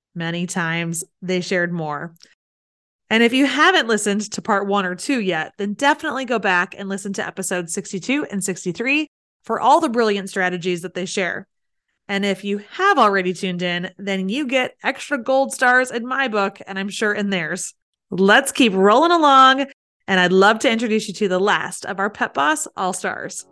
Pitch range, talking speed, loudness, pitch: 185-250 Hz, 190 wpm, -19 LUFS, 200 Hz